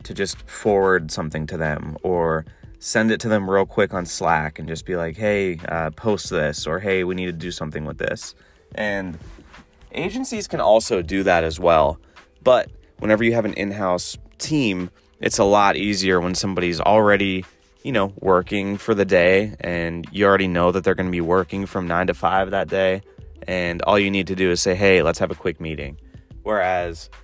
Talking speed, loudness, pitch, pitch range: 200 wpm, -21 LUFS, 95 Hz, 85-100 Hz